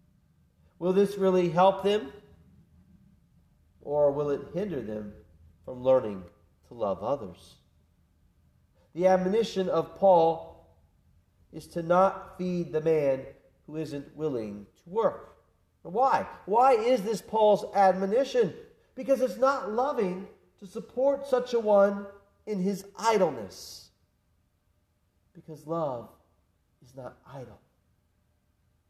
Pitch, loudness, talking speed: 170 Hz, -27 LUFS, 110 wpm